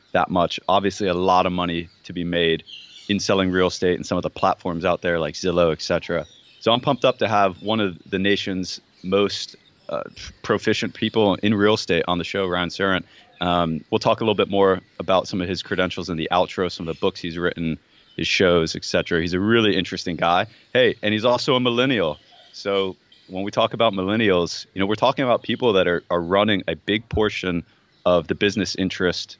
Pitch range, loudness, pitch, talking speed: 90-105 Hz, -21 LUFS, 95 Hz, 215 wpm